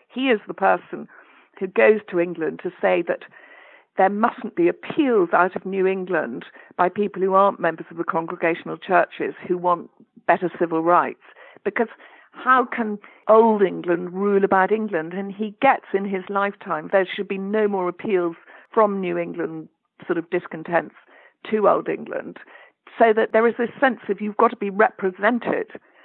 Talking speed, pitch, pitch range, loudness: 170 wpm, 195 Hz, 180-220 Hz, -21 LUFS